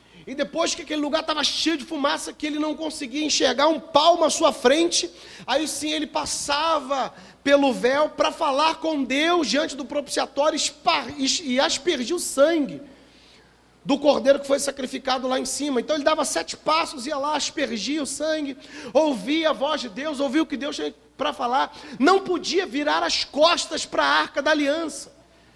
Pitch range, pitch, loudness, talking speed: 275-315 Hz, 295 Hz, -22 LUFS, 180 wpm